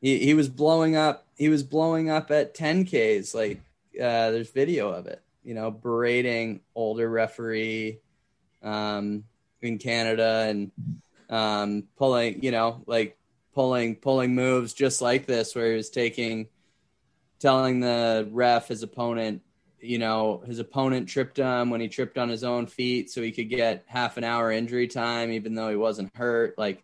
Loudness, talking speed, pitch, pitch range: -26 LUFS, 165 wpm, 120 Hz, 110-130 Hz